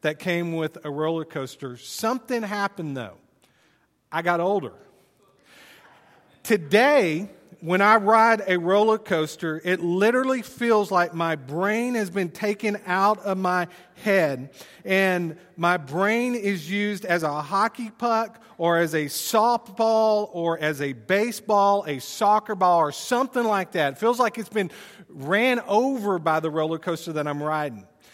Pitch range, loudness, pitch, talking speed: 160-215 Hz, -23 LUFS, 190 Hz, 150 wpm